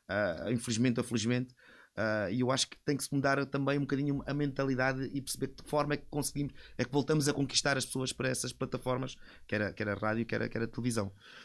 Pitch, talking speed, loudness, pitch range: 130 Hz, 235 wpm, -33 LUFS, 120-140 Hz